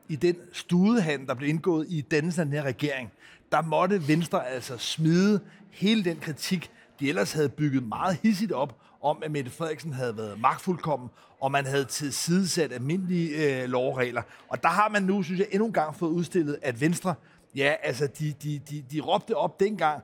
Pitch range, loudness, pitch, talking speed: 140-180 Hz, -27 LUFS, 155 Hz, 190 wpm